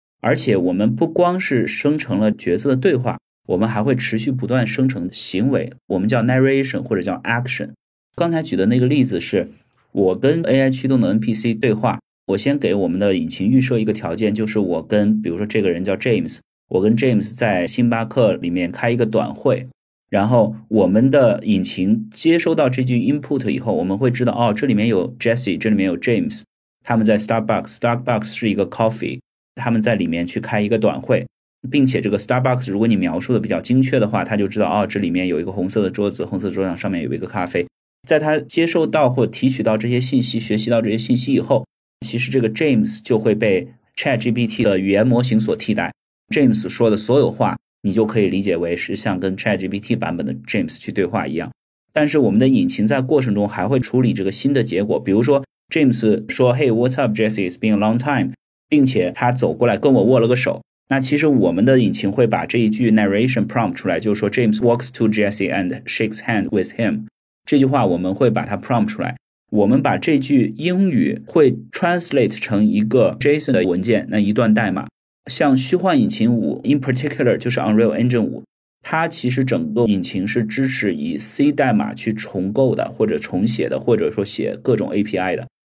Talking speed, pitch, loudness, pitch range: 425 characters per minute, 115 Hz, -18 LUFS, 105-130 Hz